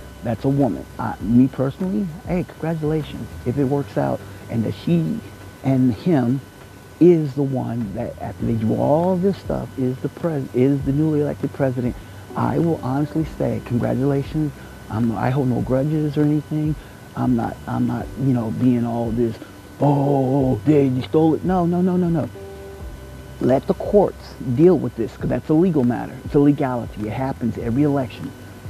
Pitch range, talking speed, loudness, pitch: 115-150 Hz, 175 wpm, -21 LUFS, 130 Hz